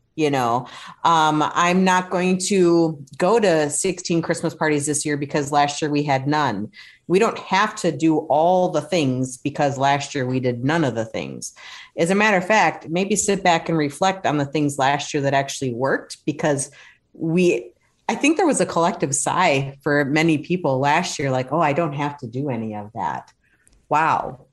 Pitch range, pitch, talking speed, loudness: 140-175 Hz, 150 Hz, 195 wpm, -20 LUFS